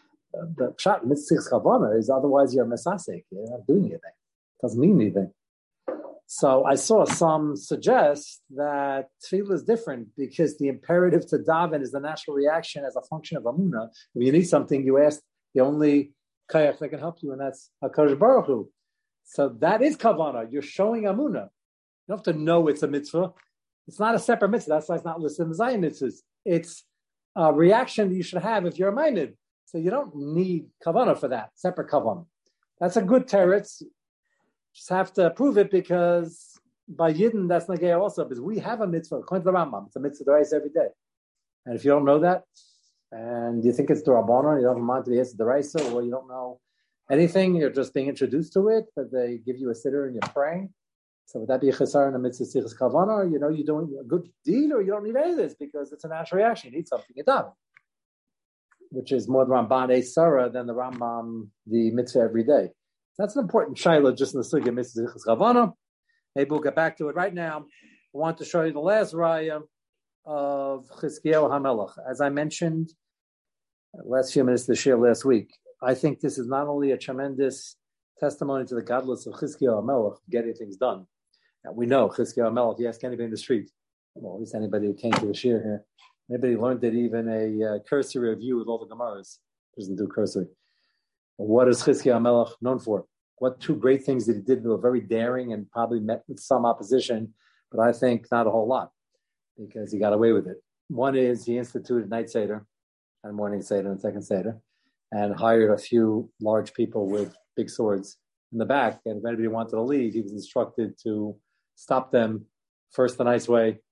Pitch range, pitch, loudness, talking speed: 120-165 Hz, 140 Hz, -24 LUFS, 205 wpm